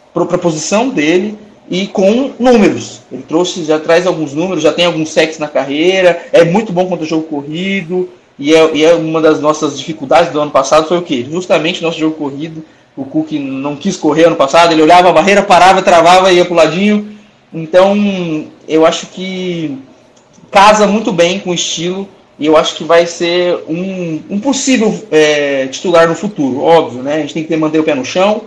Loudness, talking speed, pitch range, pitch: -11 LUFS, 195 wpm, 155-190 Hz, 170 Hz